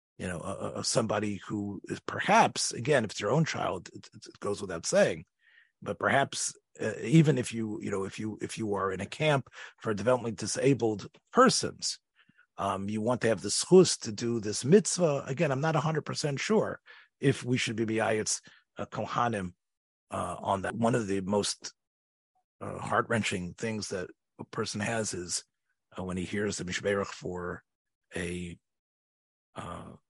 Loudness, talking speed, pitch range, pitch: -30 LUFS, 170 wpm, 100-125 Hz, 110 Hz